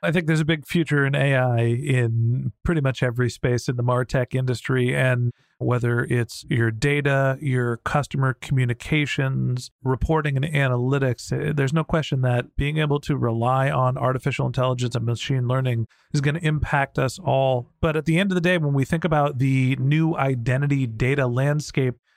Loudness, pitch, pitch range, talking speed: -22 LUFS, 135 Hz, 125-145 Hz, 175 wpm